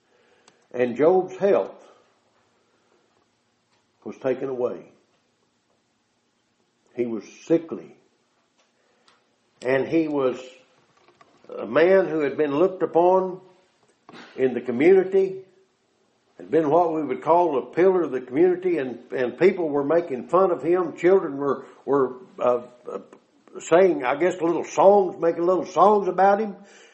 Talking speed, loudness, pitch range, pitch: 125 wpm, -22 LUFS, 135-190 Hz, 170 Hz